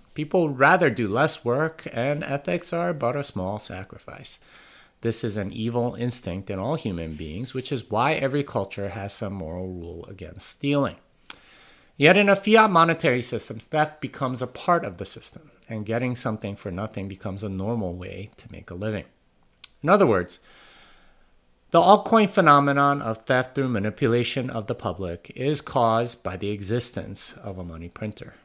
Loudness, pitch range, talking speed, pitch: -24 LUFS, 100-140 Hz, 170 wpm, 115 Hz